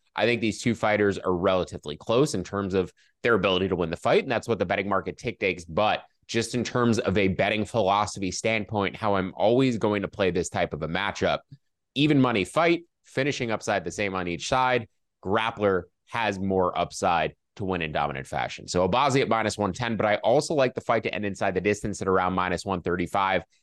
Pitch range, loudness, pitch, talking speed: 95-115 Hz, -26 LUFS, 100 Hz, 215 wpm